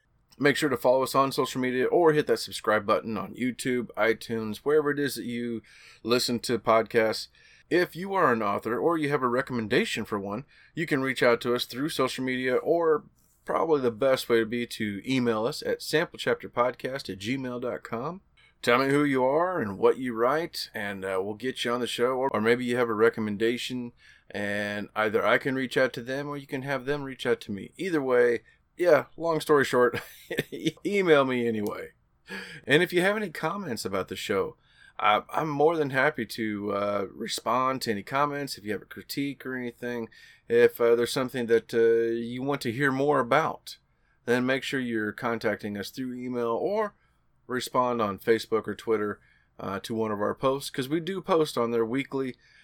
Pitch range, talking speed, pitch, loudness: 115-140 Hz, 200 wpm, 125 Hz, -27 LUFS